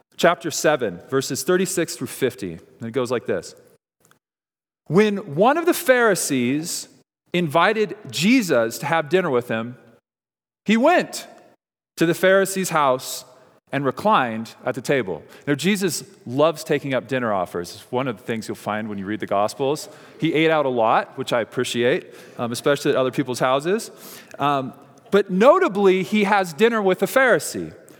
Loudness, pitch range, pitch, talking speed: -21 LUFS, 130-195 Hz, 155 Hz, 165 wpm